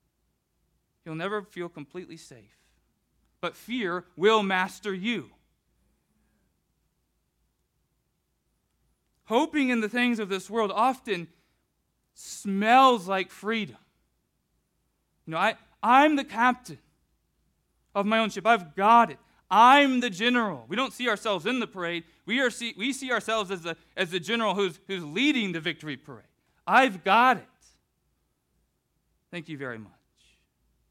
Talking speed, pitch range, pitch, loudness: 130 wpm, 175-240 Hz, 205 Hz, -25 LUFS